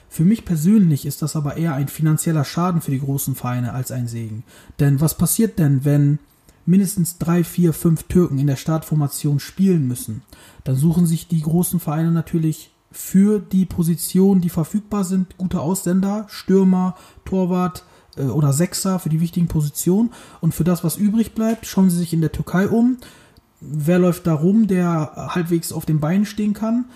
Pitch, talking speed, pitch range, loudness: 170 Hz, 175 wpm, 150-185 Hz, -19 LUFS